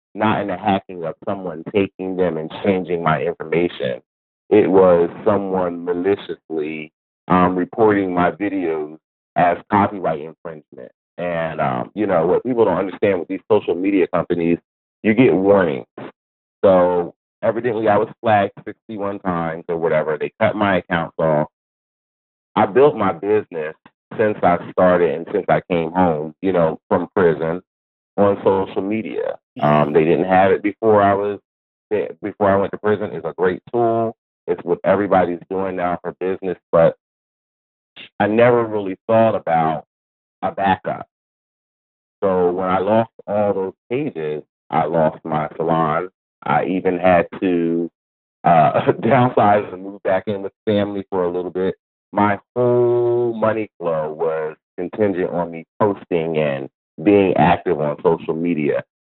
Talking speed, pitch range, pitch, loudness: 150 wpm, 85-105 Hz, 95 Hz, -19 LUFS